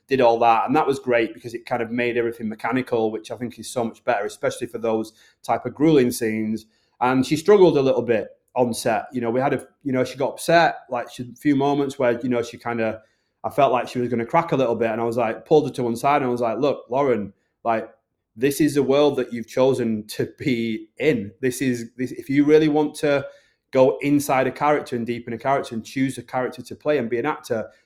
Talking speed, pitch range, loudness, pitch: 255 wpm, 115-140 Hz, -22 LUFS, 125 Hz